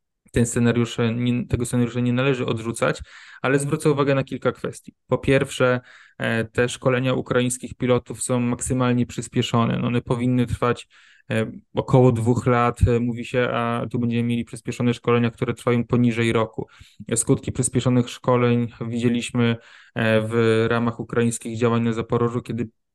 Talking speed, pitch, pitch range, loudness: 130 wpm, 120 Hz, 115-125 Hz, -22 LUFS